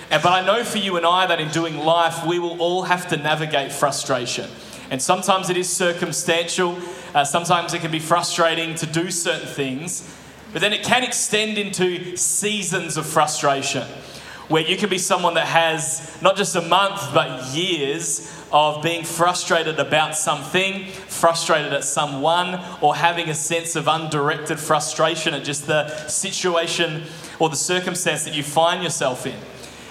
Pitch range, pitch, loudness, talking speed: 155-180 Hz, 165 Hz, -20 LUFS, 165 wpm